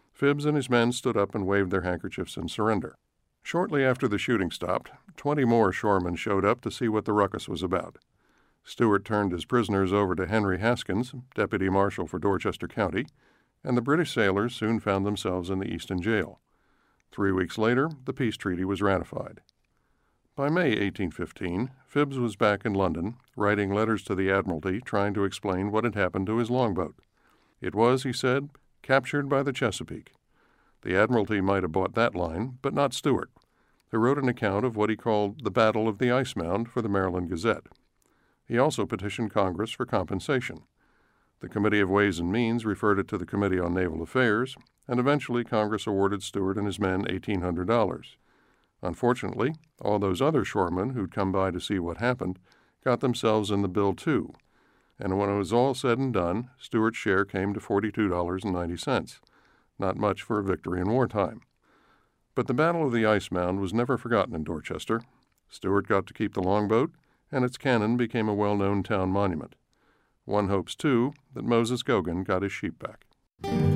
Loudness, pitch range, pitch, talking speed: -27 LUFS, 95-120 Hz, 105 Hz, 180 wpm